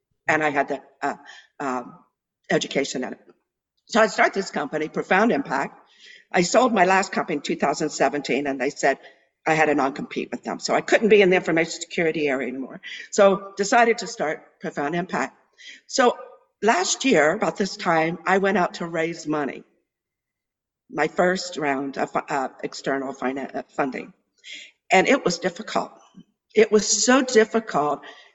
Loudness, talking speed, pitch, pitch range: -22 LUFS, 160 wpm, 180 Hz, 150-215 Hz